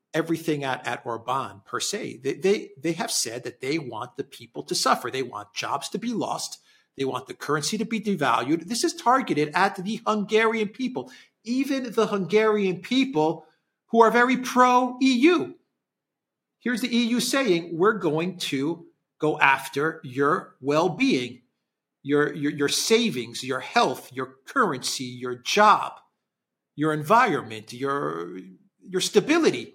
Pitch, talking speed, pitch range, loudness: 180 Hz, 150 wpm, 140-230 Hz, -24 LUFS